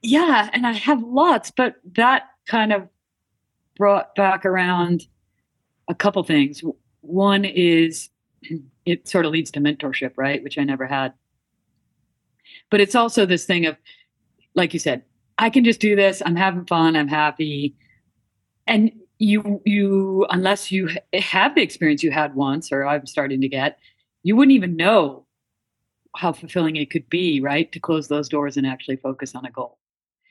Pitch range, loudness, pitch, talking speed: 140-200 Hz, -20 LUFS, 170 Hz, 165 wpm